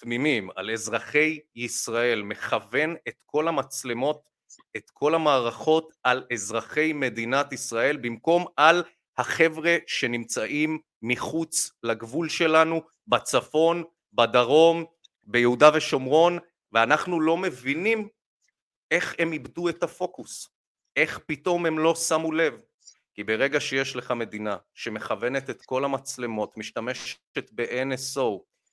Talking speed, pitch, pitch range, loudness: 105 wpm, 145 Hz, 120-165 Hz, -25 LUFS